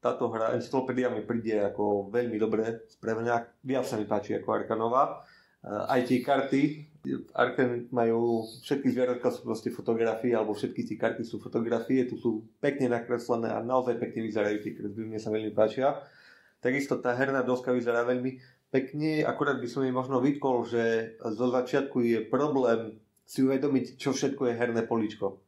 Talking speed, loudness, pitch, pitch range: 160 wpm, -29 LUFS, 120 Hz, 115-130 Hz